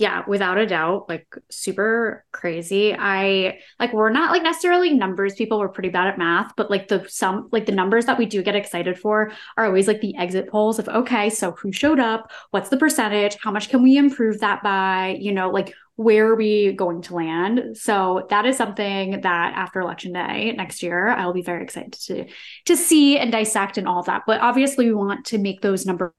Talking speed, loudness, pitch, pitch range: 220 wpm, -20 LUFS, 205 Hz, 190-225 Hz